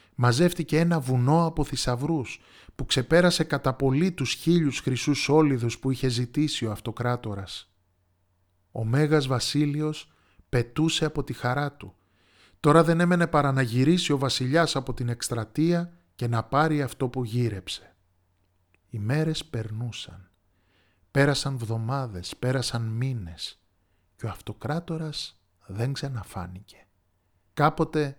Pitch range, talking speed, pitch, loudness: 100-150 Hz, 120 wpm, 125 Hz, -26 LUFS